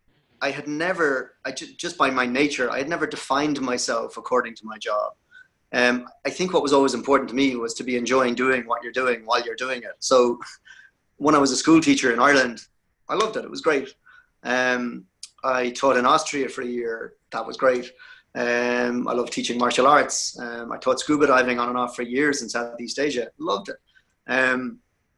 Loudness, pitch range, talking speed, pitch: -22 LUFS, 120-145 Hz, 205 wpm, 130 Hz